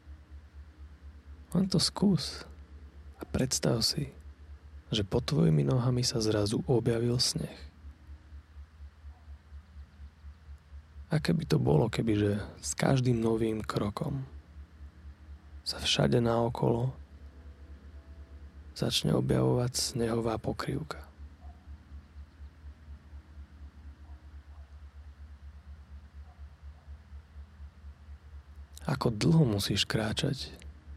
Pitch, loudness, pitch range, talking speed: 75 Hz, -30 LUFS, 75-110 Hz, 65 wpm